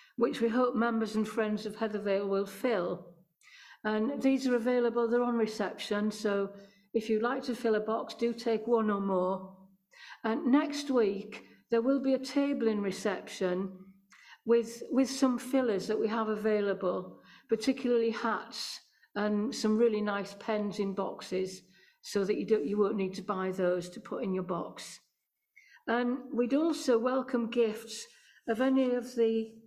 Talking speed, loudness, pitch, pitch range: 165 wpm, -31 LUFS, 225 Hz, 200-245 Hz